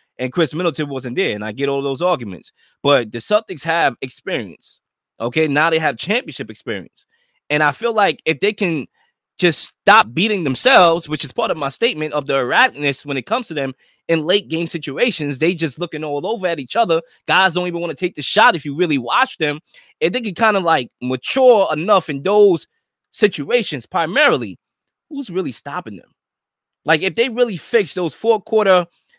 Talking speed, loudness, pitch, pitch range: 195 wpm, -17 LUFS, 165 Hz, 145-205 Hz